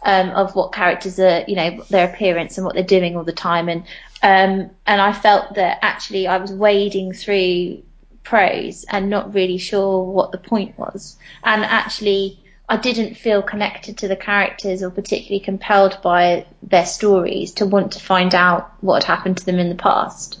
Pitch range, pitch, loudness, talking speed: 185-205 Hz, 195 Hz, -17 LUFS, 190 wpm